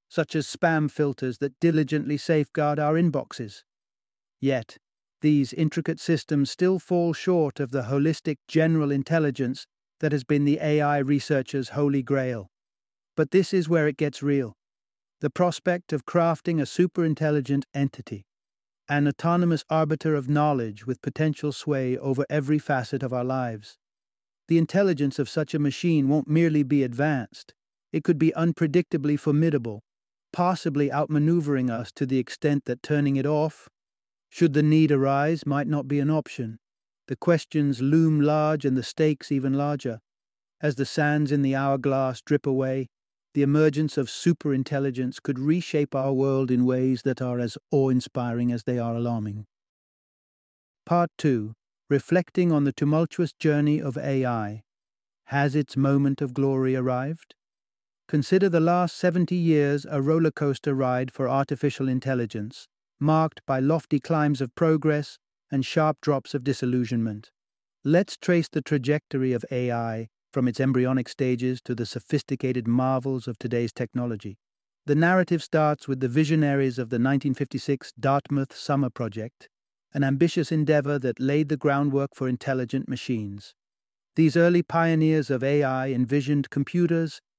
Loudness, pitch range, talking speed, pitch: -25 LUFS, 130-155 Hz, 145 wpm, 140 Hz